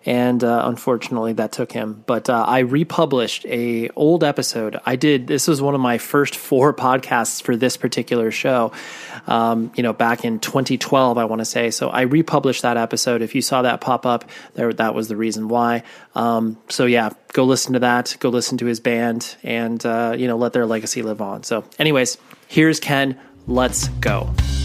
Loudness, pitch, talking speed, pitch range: -19 LUFS, 120 Hz, 195 wpm, 115-130 Hz